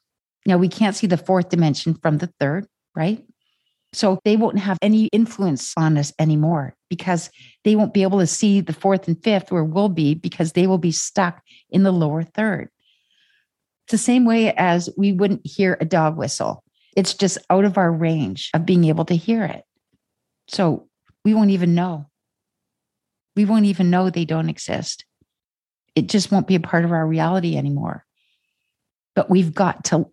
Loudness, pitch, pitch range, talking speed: -19 LUFS, 180 Hz, 160-200 Hz, 185 wpm